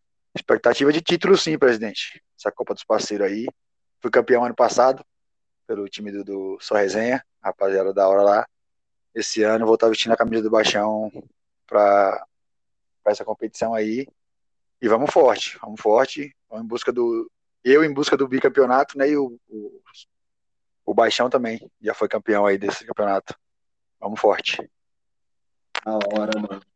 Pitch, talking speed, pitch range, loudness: 110 Hz, 155 wpm, 100-135 Hz, -21 LUFS